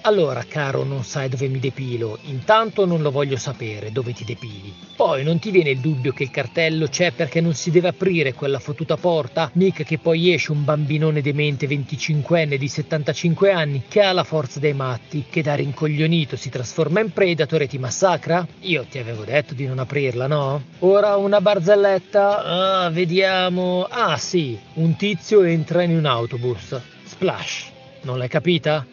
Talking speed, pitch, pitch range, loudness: 175 wpm, 155 Hz, 135-175 Hz, -20 LUFS